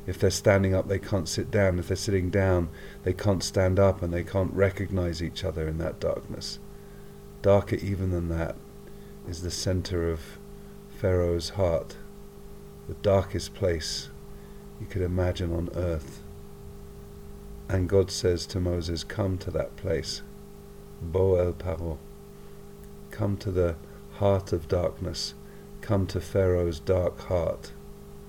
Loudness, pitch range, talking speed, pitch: -28 LUFS, 80-95 Hz, 140 wpm, 90 Hz